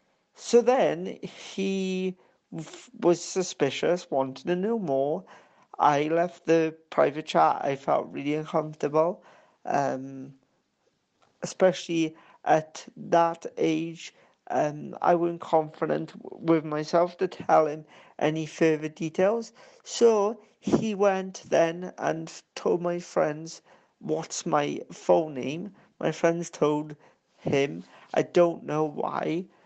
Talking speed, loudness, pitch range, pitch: 115 wpm, -27 LUFS, 155-185 Hz, 165 Hz